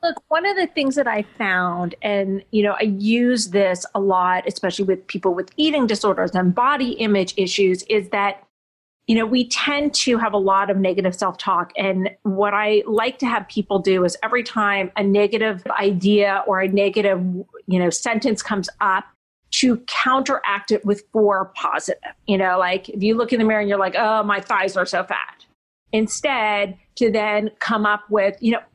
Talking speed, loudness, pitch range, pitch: 195 wpm, -20 LUFS, 195-225 Hz, 205 Hz